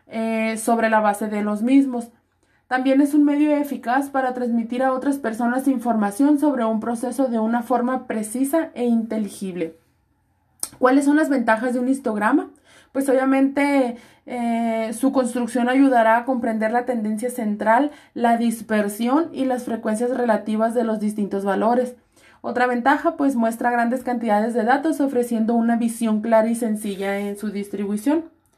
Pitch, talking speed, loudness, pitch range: 240 Hz, 150 wpm, -21 LUFS, 220-265 Hz